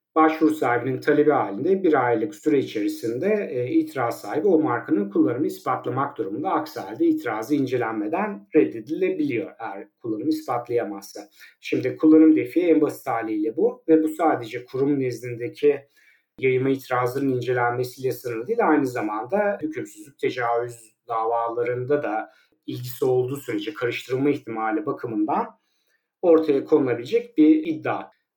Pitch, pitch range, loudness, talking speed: 150 Hz, 125-205 Hz, -23 LUFS, 120 wpm